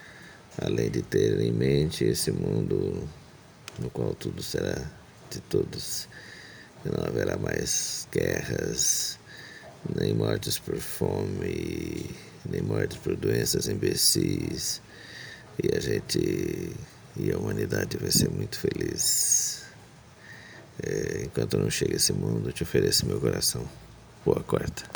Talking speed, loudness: 120 wpm, -27 LUFS